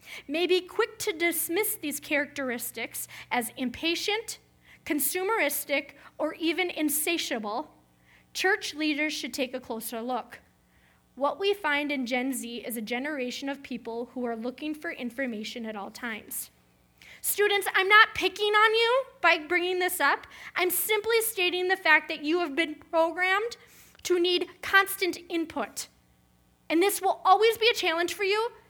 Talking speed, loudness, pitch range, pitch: 150 wpm, -27 LUFS, 255-375 Hz, 325 Hz